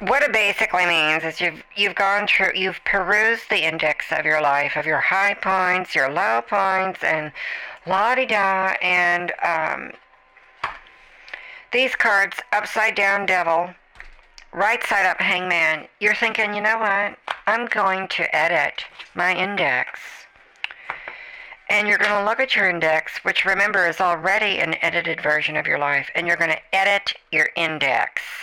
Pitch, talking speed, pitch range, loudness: 190 Hz, 150 wpm, 165-205 Hz, -19 LUFS